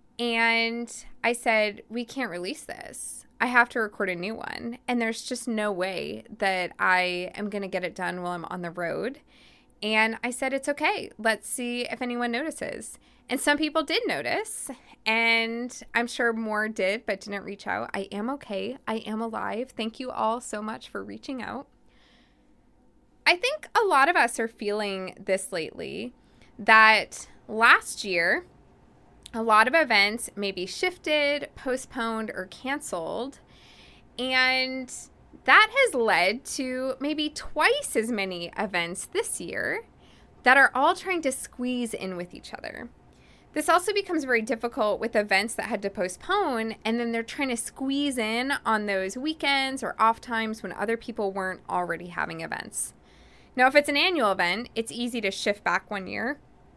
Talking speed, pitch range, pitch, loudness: 170 wpm, 210-260 Hz, 230 Hz, -26 LUFS